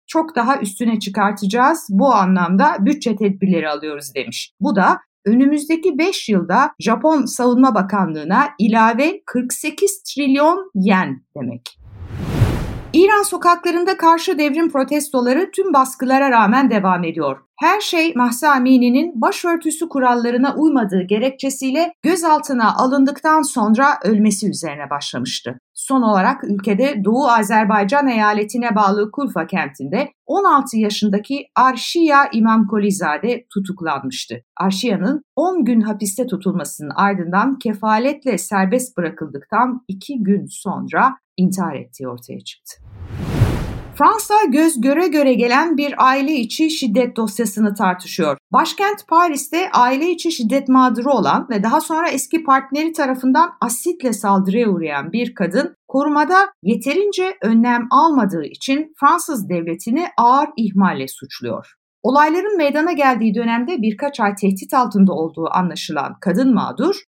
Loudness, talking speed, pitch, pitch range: -16 LUFS, 115 wpm, 245 Hz, 205-295 Hz